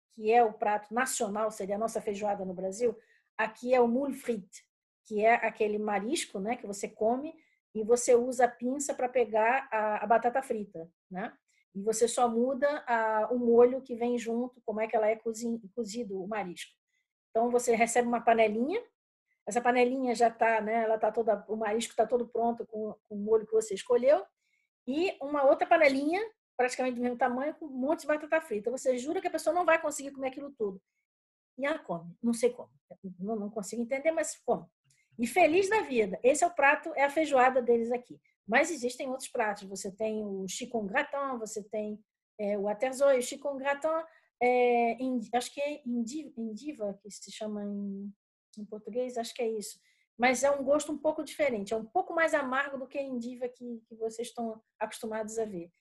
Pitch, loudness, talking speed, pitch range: 240 Hz, -30 LUFS, 200 wpm, 220-275 Hz